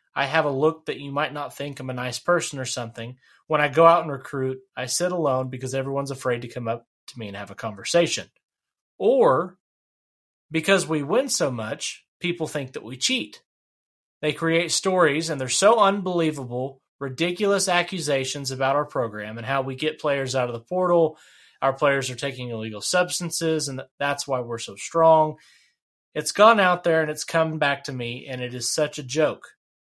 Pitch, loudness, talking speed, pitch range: 140 Hz, -23 LUFS, 195 wpm, 130-160 Hz